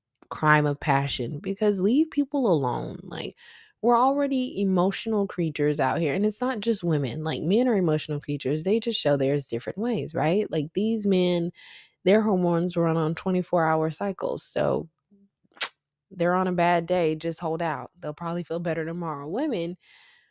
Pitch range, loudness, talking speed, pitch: 155-205 Hz, -25 LUFS, 165 wpm, 175 Hz